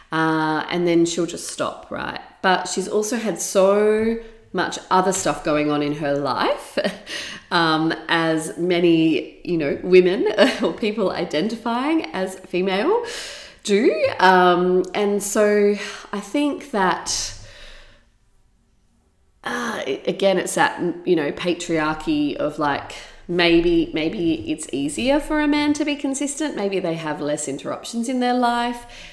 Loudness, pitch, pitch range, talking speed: -21 LUFS, 190 Hz, 170-245 Hz, 135 wpm